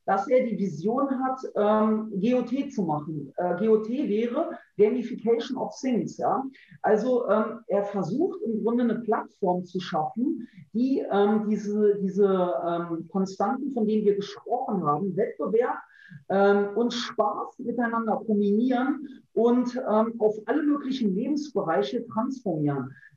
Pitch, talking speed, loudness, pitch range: 215 Hz, 130 wpm, -26 LUFS, 200-245 Hz